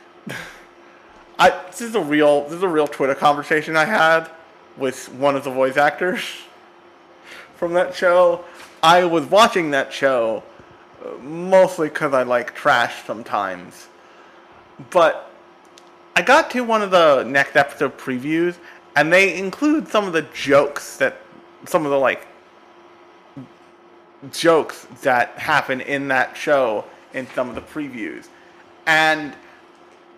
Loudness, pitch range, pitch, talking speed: -18 LUFS, 140-185 Hz, 160 Hz, 135 wpm